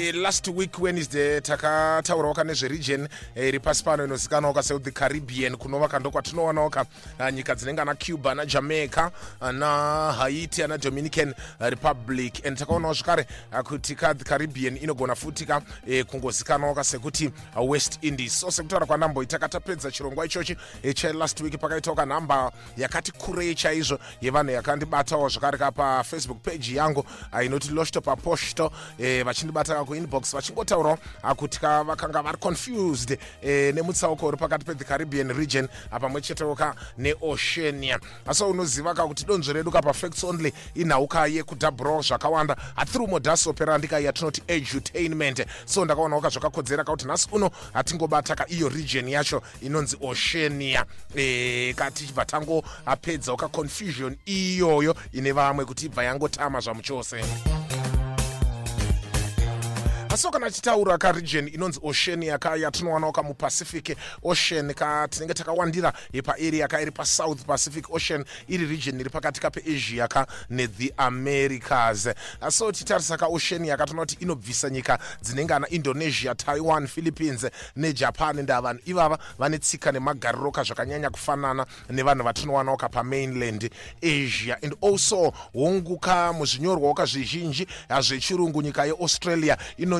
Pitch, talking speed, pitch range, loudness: 150 Hz, 125 wpm, 135-160 Hz, -25 LUFS